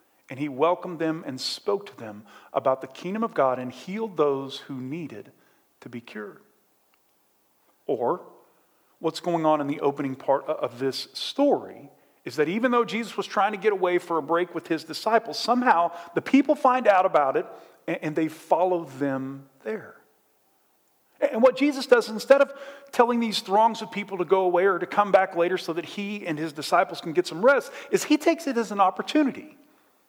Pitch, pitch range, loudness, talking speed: 180 Hz, 155-230 Hz, -25 LUFS, 190 wpm